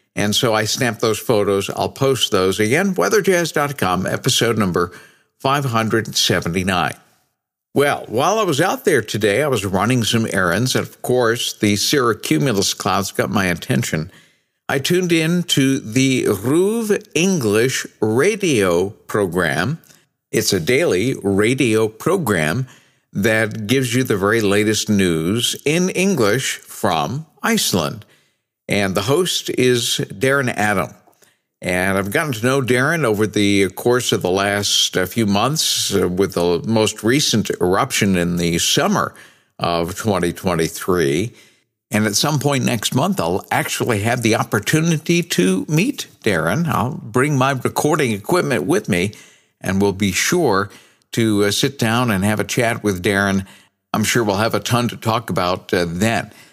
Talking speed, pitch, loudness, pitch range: 140 wpm, 115 Hz, -18 LUFS, 100-135 Hz